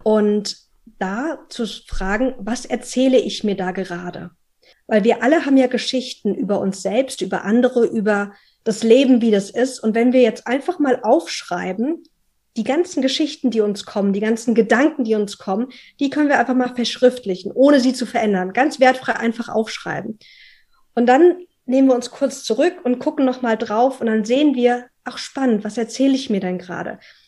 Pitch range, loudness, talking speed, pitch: 215-260 Hz, -18 LUFS, 185 wpm, 240 Hz